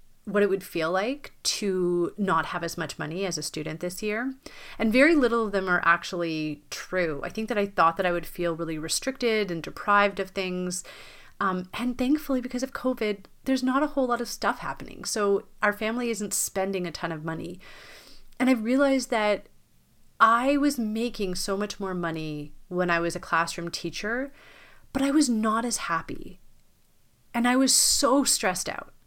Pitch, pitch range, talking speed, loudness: 205 Hz, 175-245 Hz, 190 wpm, -26 LUFS